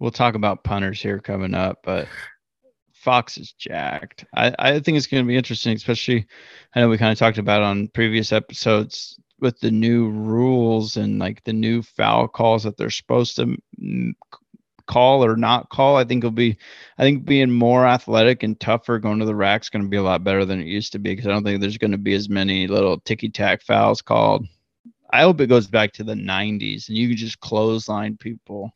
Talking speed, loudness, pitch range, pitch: 210 wpm, -19 LUFS, 105-120 Hz, 110 Hz